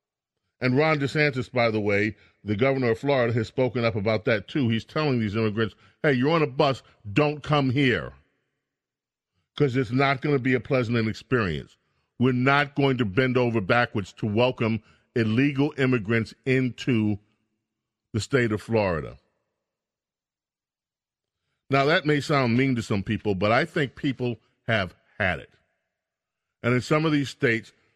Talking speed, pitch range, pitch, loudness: 160 wpm, 110-140 Hz, 120 Hz, -24 LUFS